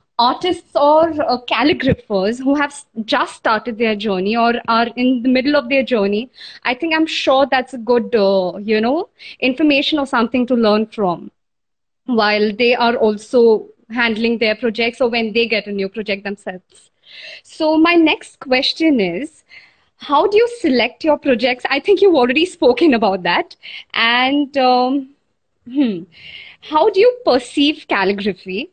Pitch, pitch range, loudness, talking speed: 250 Hz, 220-290 Hz, -16 LUFS, 155 wpm